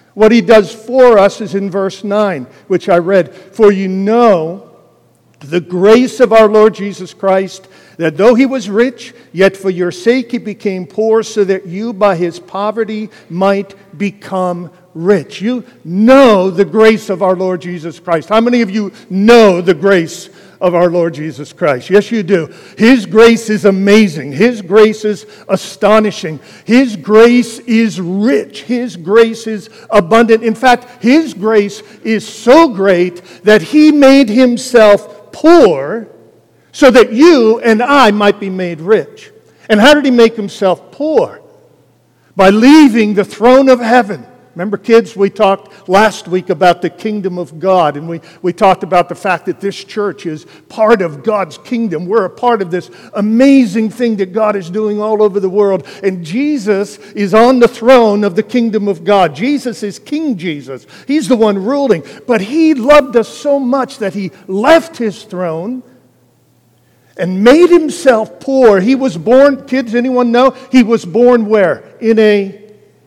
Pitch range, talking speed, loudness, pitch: 190-235 Hz, 170 wpm, -10 LUFS, 210 Hz